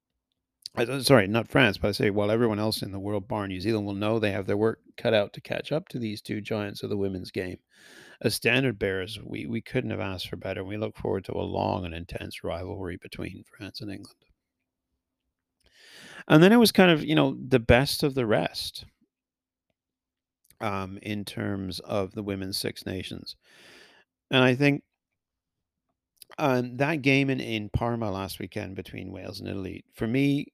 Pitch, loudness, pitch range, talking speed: 110 Hz, -26 LUFS, 100-130 Hz, 190 wpm